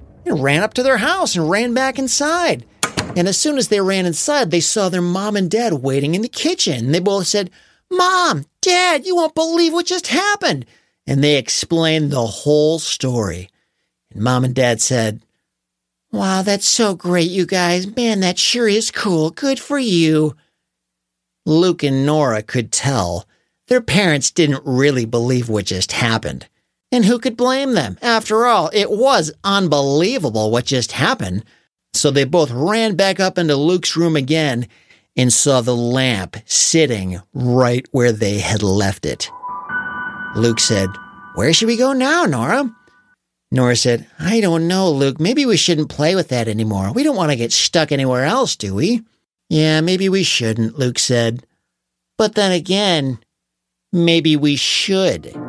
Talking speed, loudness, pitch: 165 wpm, -16 LUFS, 160 Hz